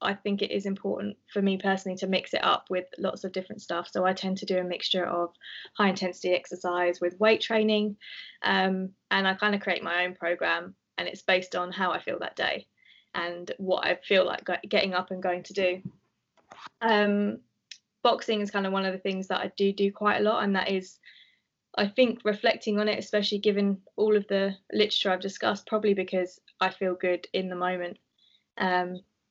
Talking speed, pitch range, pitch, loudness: 205 wpm, 180-205 Hz, 190 Hz, -28 LUFS